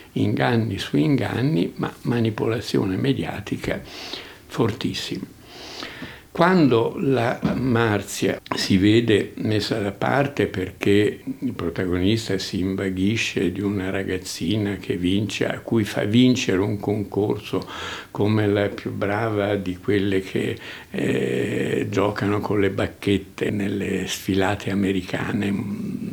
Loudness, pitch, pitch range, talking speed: -23 LUFS, 100 Hz, 95-115 Hz, 105 wpm